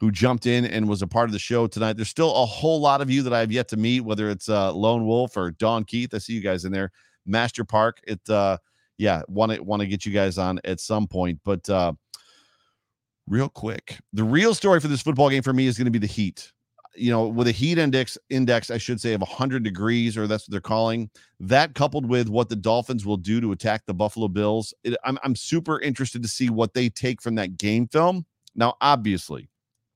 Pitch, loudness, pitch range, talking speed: 115 Hz, -23 LUFS, 105-125 Hz, 240 wpm